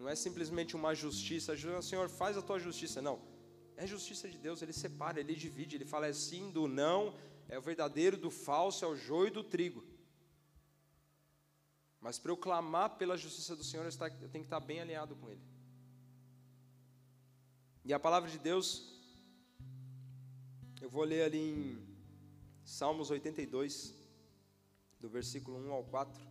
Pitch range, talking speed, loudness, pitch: 130-165 Hz, 165 wpm, -39 LUFS, 150 Hz